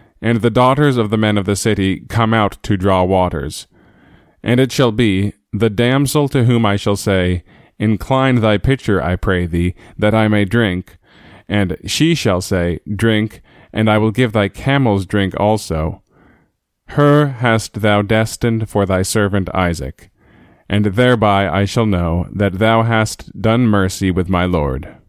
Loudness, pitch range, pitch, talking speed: -15 LUFS, 95-115 Hz, 105 Hz, 165 wpm